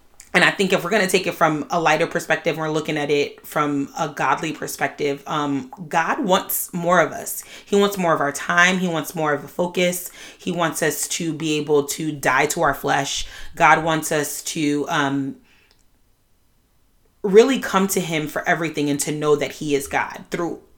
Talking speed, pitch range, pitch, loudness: 200 wpm, 145-175 Hz, 155 Hz, -20 LUFS